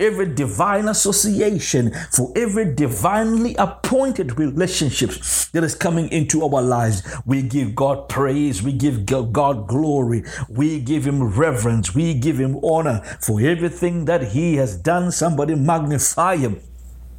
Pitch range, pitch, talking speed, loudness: 125-170 Hz, 145 Hz, 135 wpm, -19 LUFS